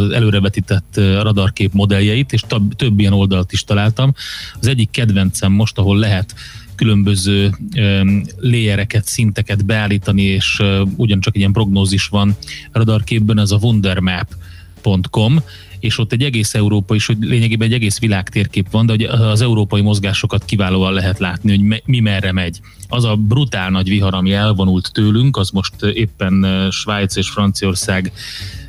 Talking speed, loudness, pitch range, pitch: 150 wpm, -15 LUFS, 95-110 Hz, 105 Hz